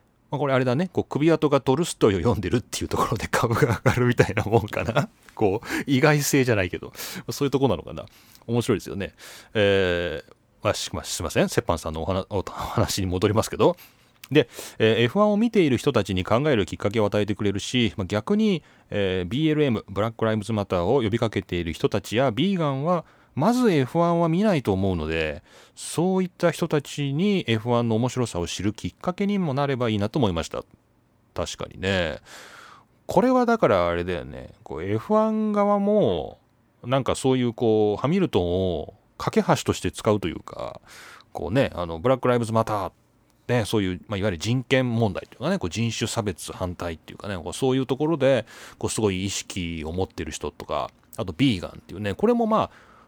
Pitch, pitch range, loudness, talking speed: 115 Hz, 100-145 Hz, -24 LUFS, 390 characters per minute